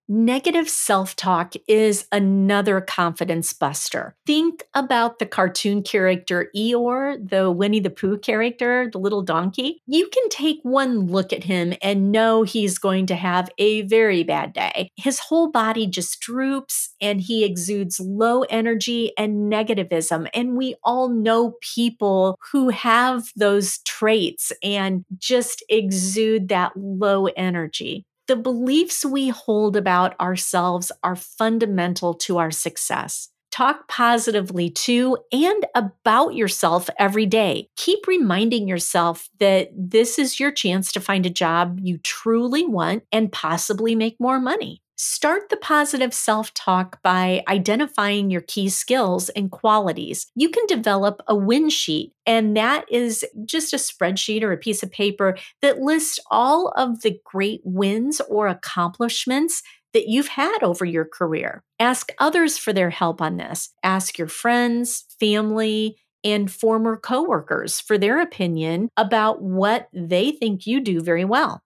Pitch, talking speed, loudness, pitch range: 215 Hz, 145 wpm, -21 LUFS, 190-245 Hz